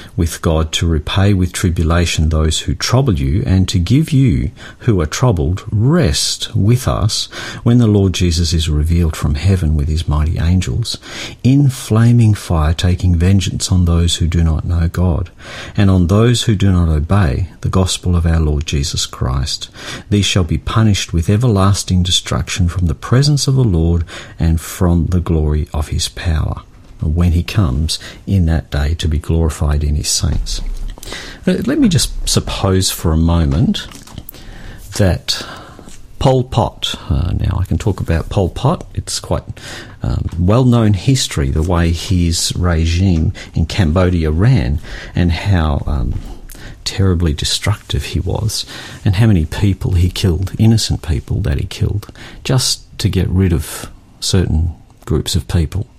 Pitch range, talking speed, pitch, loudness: 85-110 Hz, 160 wpm, 95 Hz, -15 LUFS